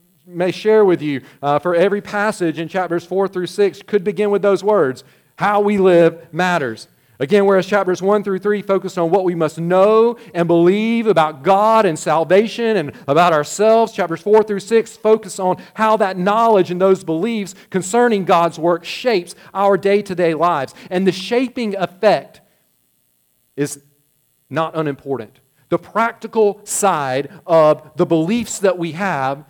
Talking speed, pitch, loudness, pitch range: 165 wpm, 185 Hz, -16 LUFS, 165-210 Hz